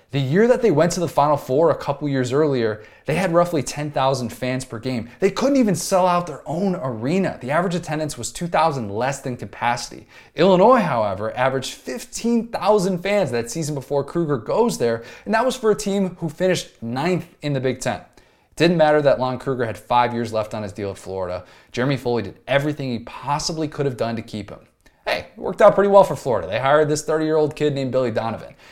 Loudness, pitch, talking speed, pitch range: -21 LUFS, 145 Hz, 220 wpm, 120-175 Hz